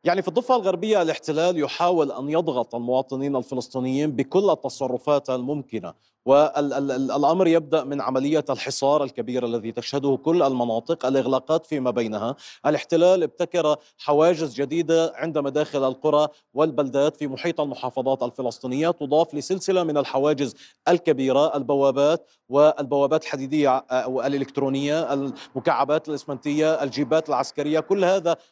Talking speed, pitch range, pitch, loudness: 115 wpm, 135-160 Hz, 145 Hz, -23 LUFS